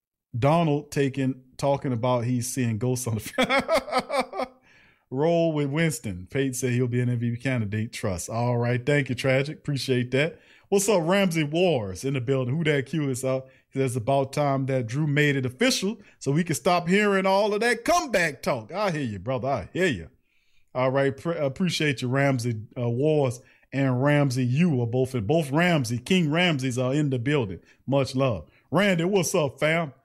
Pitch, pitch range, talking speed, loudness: 135 Hz, 125-165 Hz, 185 wpm, -25 LUFS